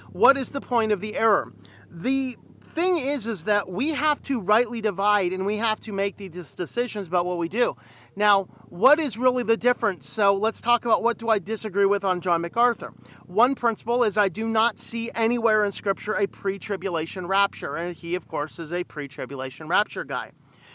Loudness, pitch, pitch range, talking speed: -24 LUFS, 210 Hz, 185-235 Hz, 195 wpm